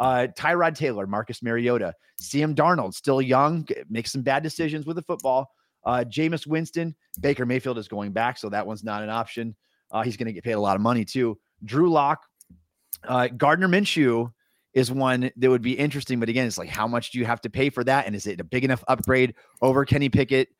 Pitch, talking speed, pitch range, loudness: 130 Hz, 220 wpm, 115-140 Hz, -24 LUFS